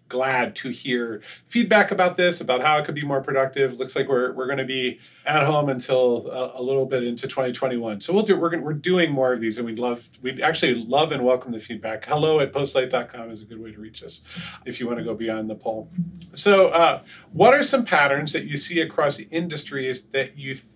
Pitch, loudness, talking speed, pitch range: 135 Hz, -22 LUFS, 235 wpm, 120-155 Hz